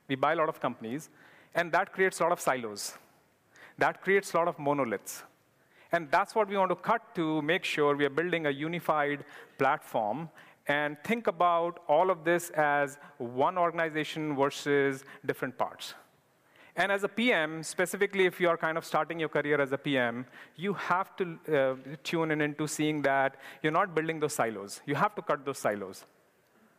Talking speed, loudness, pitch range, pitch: 185 wpm, -30 LUFS, 145-175 Hz, 160 Hz